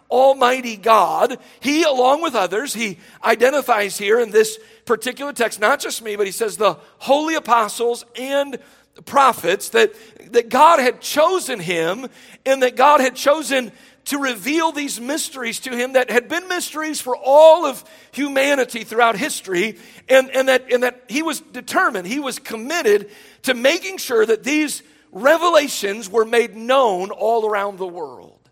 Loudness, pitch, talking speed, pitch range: -18 LUFS, 260 Hz, 160 wpm, 230-300 Hz